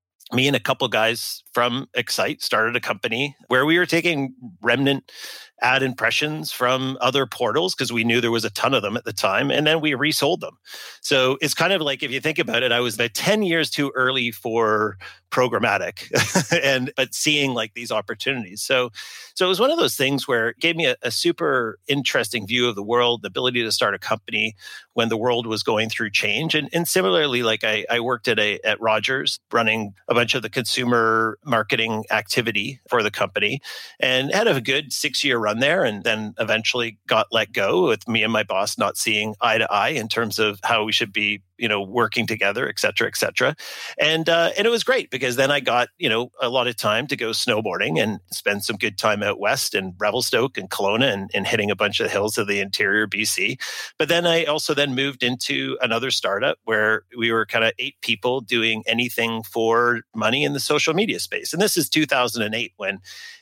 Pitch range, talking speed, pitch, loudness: 110-140 Hz, 215 wpm, 120 Hz, -21 LUFS